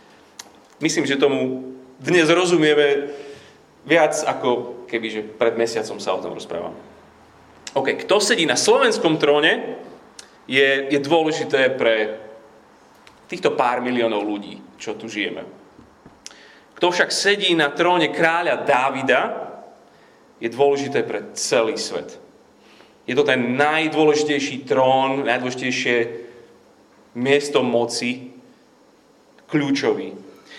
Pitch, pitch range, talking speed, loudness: 140 Hz, 120-150 Hz, 105 wpm, -19 LUFS